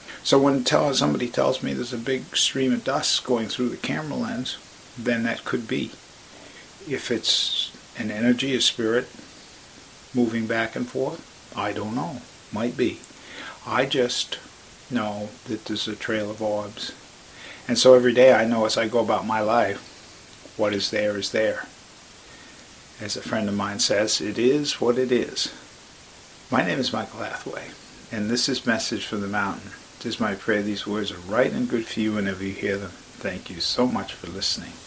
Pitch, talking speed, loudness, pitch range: 115 Hz, 180 wpm, -24 LUFS, 105-125 Hz